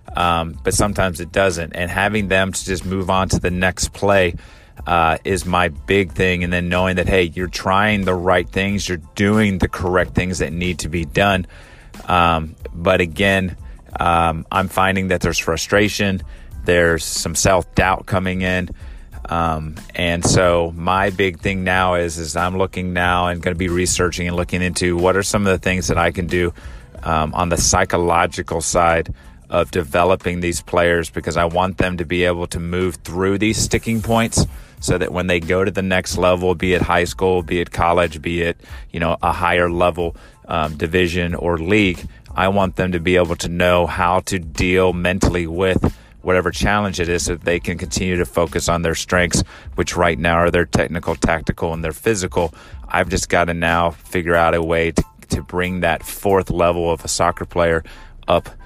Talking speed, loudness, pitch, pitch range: 195 wpm, -18 LUFS, 90 Hz, 85-95 Hz